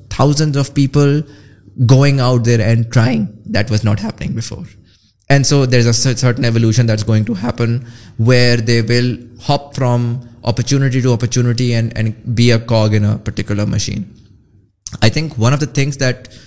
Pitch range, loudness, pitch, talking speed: 110-130 Hz, -14 LUFS, 120 Hz, 175 wpm